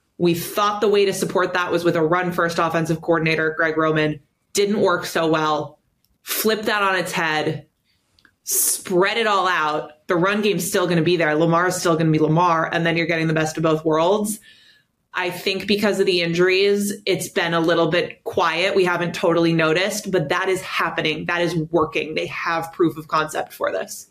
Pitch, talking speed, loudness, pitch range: 175 Hz, 205 wpm, -20 LUFS, 160-190 Hz